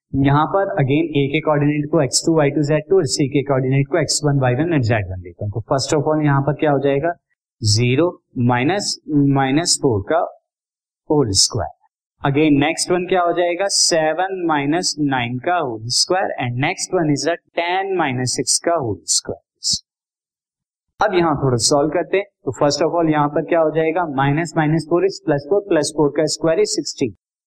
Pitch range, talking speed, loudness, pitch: 140-170 Hz, 175 wpm, -18 LUFS, 155 Hz